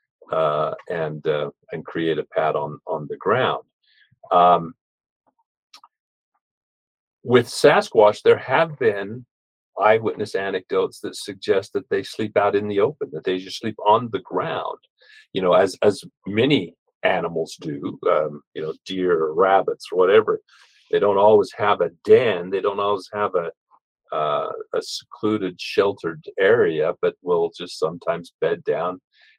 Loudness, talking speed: -21 LUFS, 145 wpm